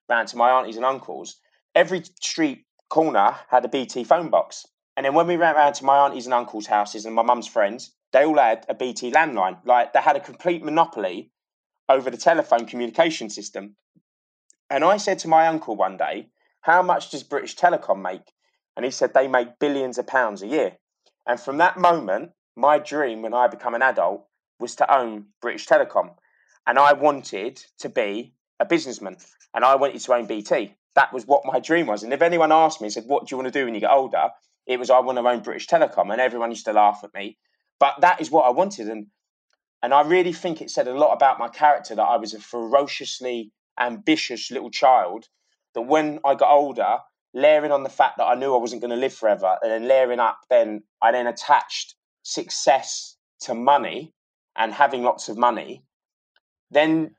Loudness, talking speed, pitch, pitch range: -21 LUFS, 210 wpm, 130 Hz, 120-155 Hz